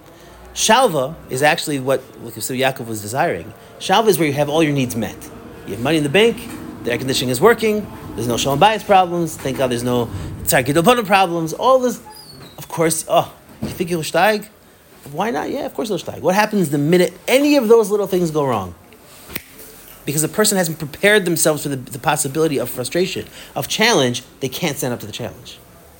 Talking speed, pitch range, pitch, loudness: 200 wpm, 130-190 Hz, 155 Hz, -17 LUFS